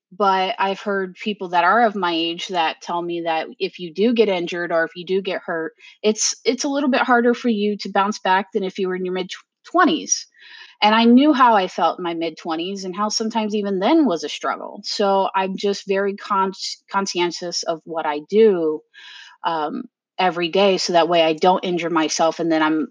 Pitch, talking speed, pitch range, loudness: 190 Hz, 220 wpm, 170-210 Hz, -20 LUFS